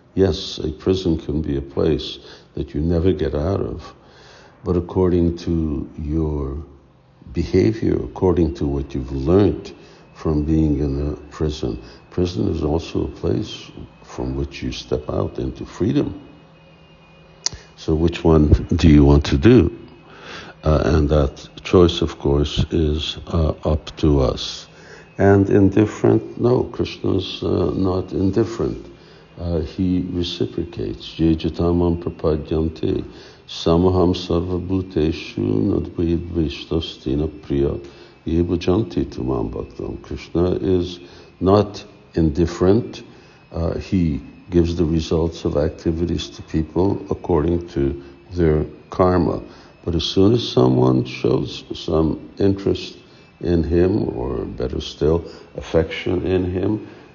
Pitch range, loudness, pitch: 75-90 Hz, -20 LUFS, 85 Hz